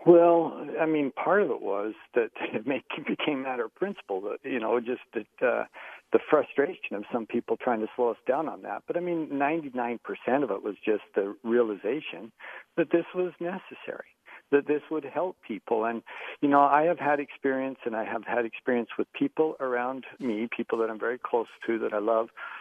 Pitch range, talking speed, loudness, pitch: 120-170 Hz, 205 wpm, -28 LUFS, 140 Hz